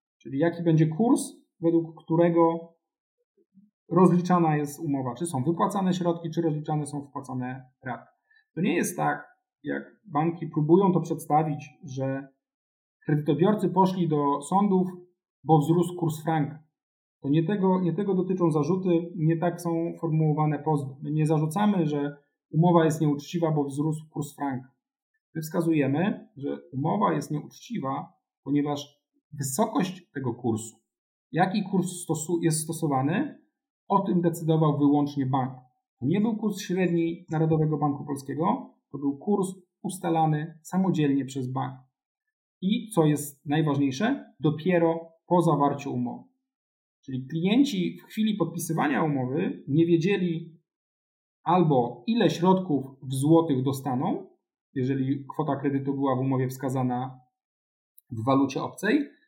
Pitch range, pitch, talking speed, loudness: 145-180 Hz, 160 Hz, 125 wpm, -26 LUFS